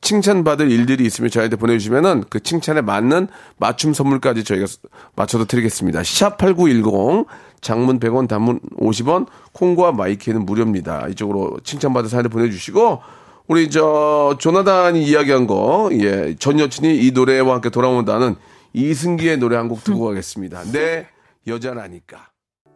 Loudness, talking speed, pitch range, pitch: -17 LUFS, 335 characters per minute, 110-150 Hz, 125 Hz